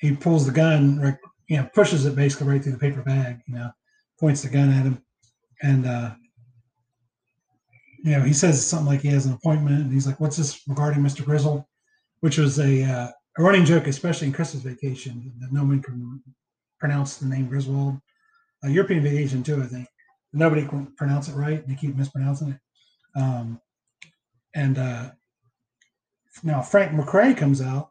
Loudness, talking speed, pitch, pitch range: -22 LUFS, 180 wpm, 140 Hz, 130-150 Hz